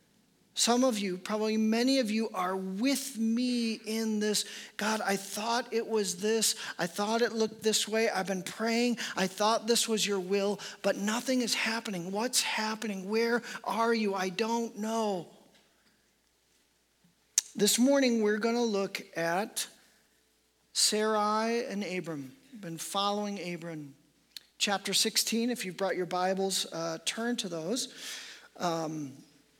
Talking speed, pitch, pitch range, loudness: 140 wpm, 215 Hz, 190-230 Hz, -30 LUFS